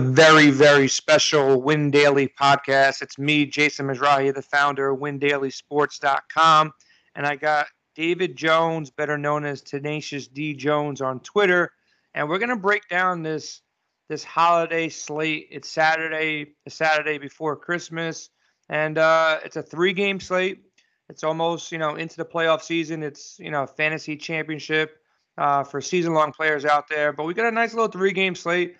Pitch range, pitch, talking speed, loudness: 145-165 Hz, 155 Hz, 165 wpm, -21 LUFS